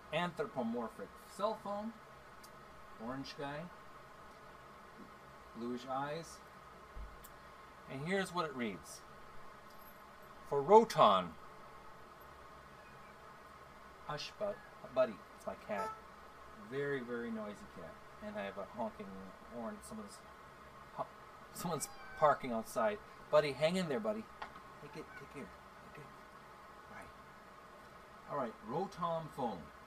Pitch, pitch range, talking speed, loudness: 210 Hz, 210-215 Hz, 100 wpm, -38 LUFS